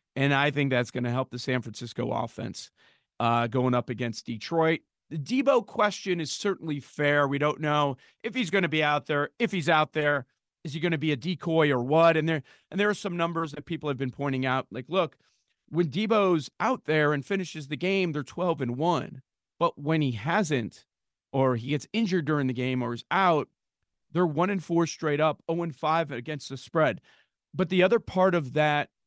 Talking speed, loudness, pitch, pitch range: 215 wpm, -27 LUFS, 150 Hz, 135-175 Hz